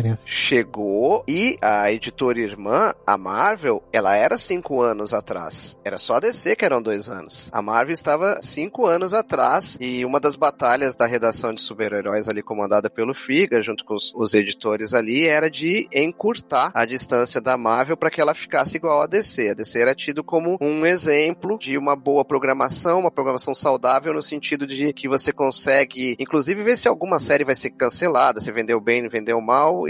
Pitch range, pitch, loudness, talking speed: 115-155 Hz, 135 Hz, -20 LUFS, 185 wpm